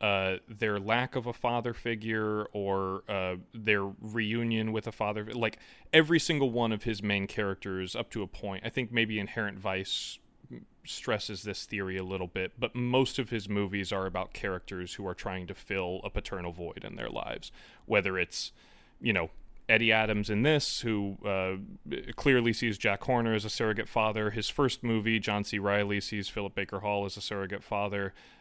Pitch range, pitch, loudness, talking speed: 100-115 Hz, 105 Hz, -31 LUFS, 185 wpm